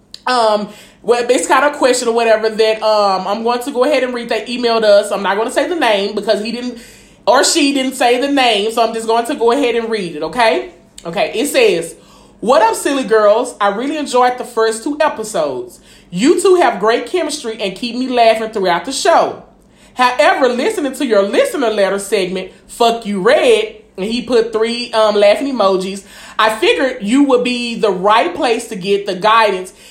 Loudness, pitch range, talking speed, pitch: -14 LUFS, 210-255 Hz, 205 wpm, 230 Hz